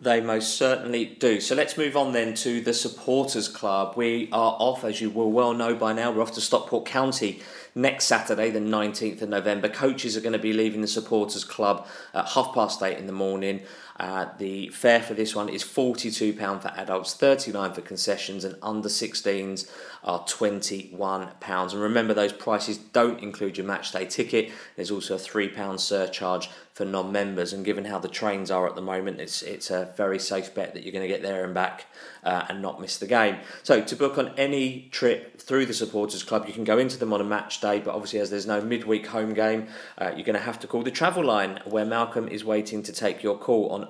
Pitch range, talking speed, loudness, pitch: 95-115 Hz, 225 wpm, -26 LUFS, 105 Hz